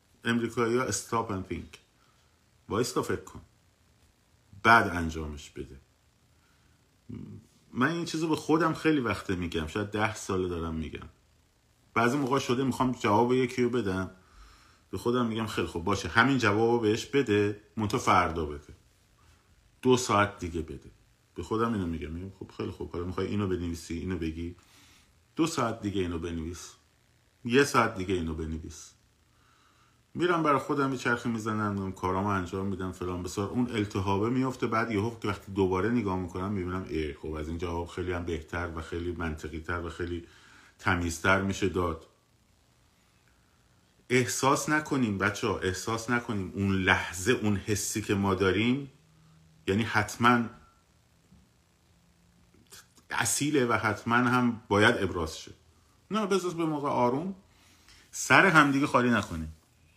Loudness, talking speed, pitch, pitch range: -29 LUFS, 145 wpm, 100 Hz, 90-120 Hz